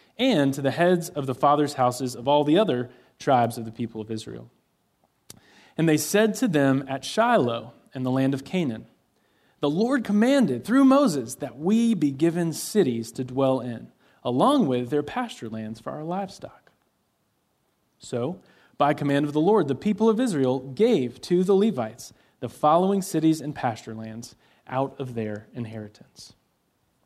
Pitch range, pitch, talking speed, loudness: 125-190 Hz, 145 Hz, 165 wpm, -24 LUFS